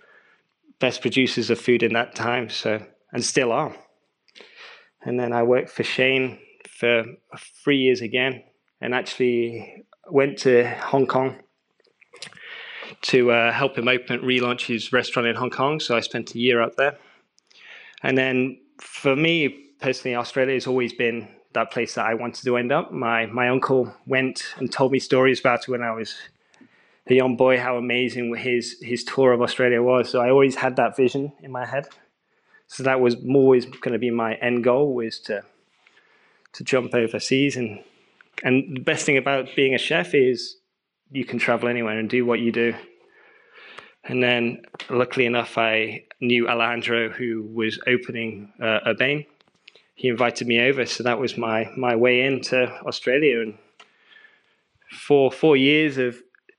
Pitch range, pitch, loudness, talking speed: 120-130 Hz, 125 Hz, -22 LUFS, 170 wpm